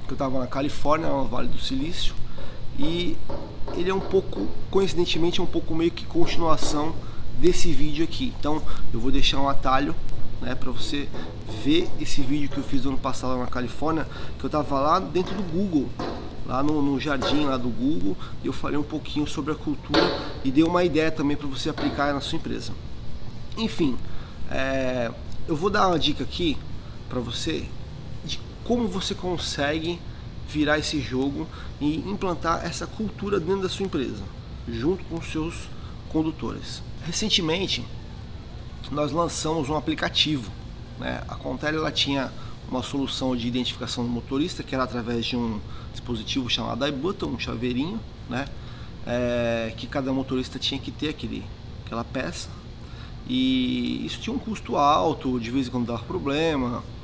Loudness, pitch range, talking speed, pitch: -26 LUFS, 125-160 Hz, 160 wpm, 140 Hz